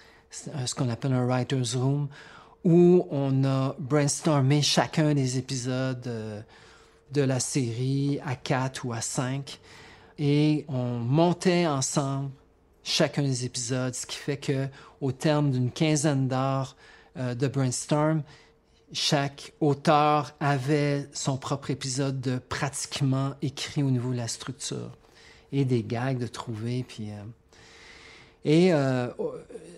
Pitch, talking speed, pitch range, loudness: 135 Hz, 125 wpm, 125-150 Hz, -27 LUFS